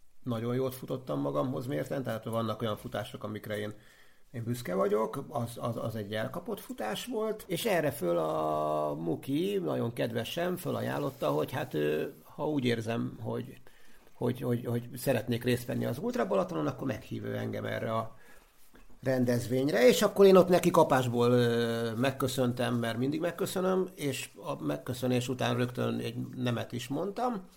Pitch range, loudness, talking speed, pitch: 115-145 Hz, -31 LUFS, 150 wpm, 125 Hz